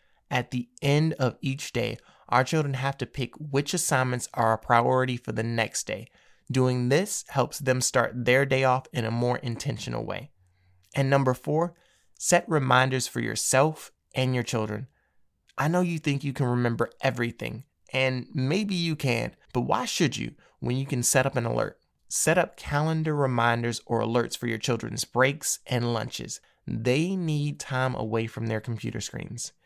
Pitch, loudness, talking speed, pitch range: 130 Hz, -27 LUFS, 175 wpm, 120-140 Hz